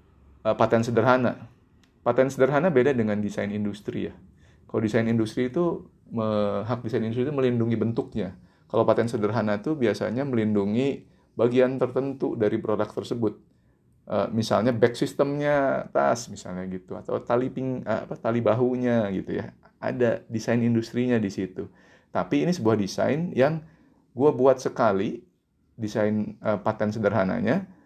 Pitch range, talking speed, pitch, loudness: 105-130 Hz, 130 wpm, 115 Hz, -25 LUFS